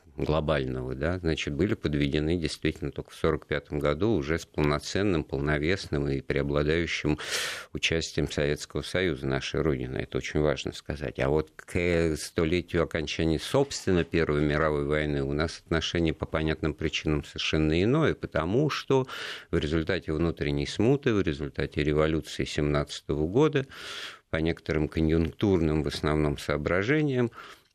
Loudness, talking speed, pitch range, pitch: -28 LUFS, 130 wpm, 75-85 Hz, 80 Hz